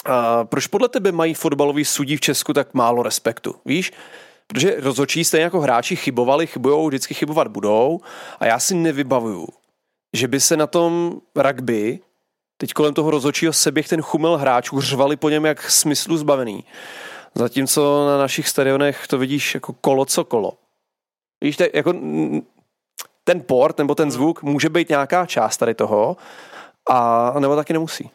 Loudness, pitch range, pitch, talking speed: -18 LUFS, 135-160 Hz, 145 Hz, 160 wpm